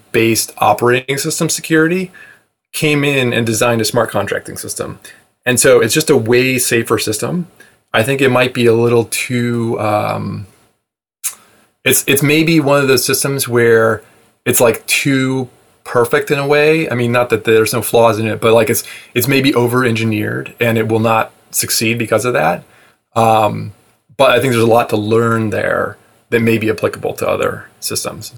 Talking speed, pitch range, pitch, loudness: 180 wpm, 110-135 Hz, 120 Hz, -14 LUFS